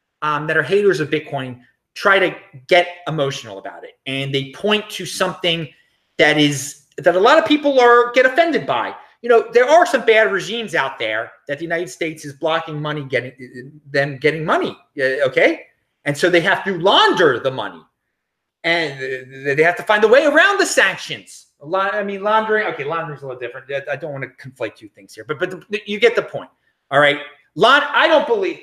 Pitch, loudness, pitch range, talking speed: 170 Hz, -17 LUFS, 145-215 Hz, 210 wpm